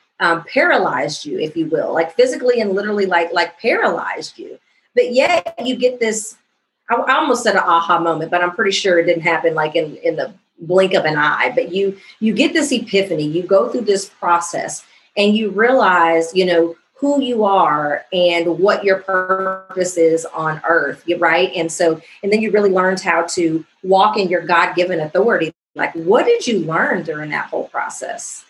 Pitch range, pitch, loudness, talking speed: 170-215 Hz, 185 Hz, -16 LUFS, 195 wpm